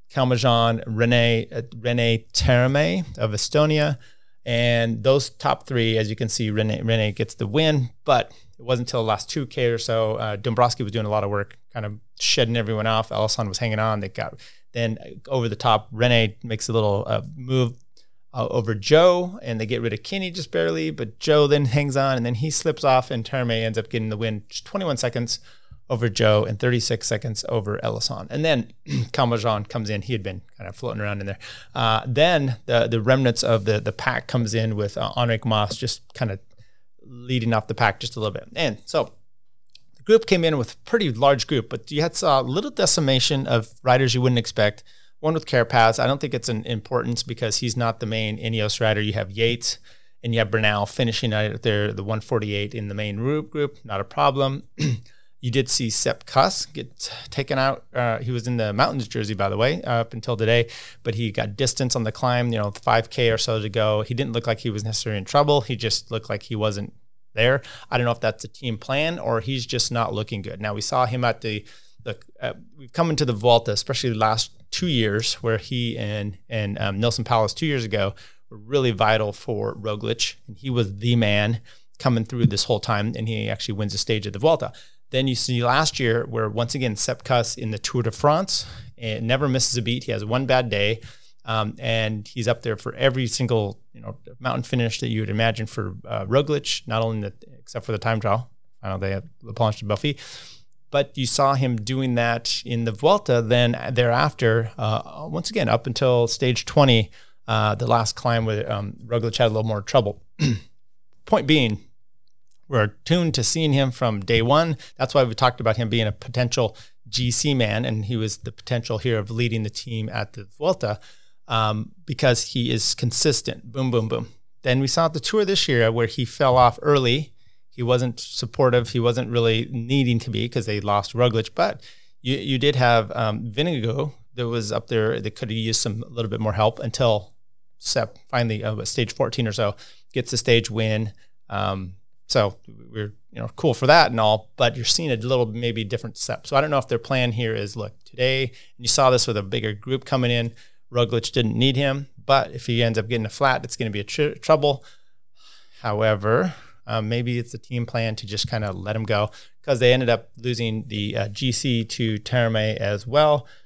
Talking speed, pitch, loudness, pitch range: 215 wpm, 115 Hz, -22 LUFS, 110-125 Hz